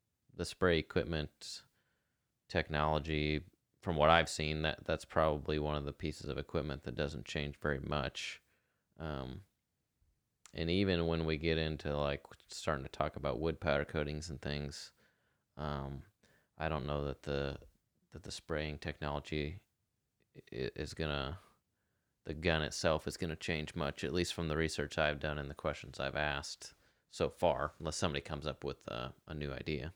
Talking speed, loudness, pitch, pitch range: 160 wpm, -37 LUFS, 75 Hz, 75-80 Hz